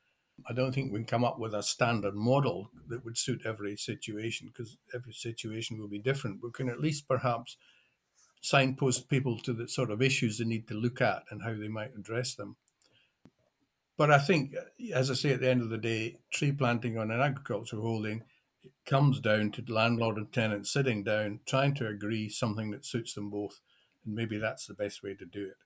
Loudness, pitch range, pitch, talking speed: -31 LUFS, 110-130 Hz, 115 Hz, 210 wpm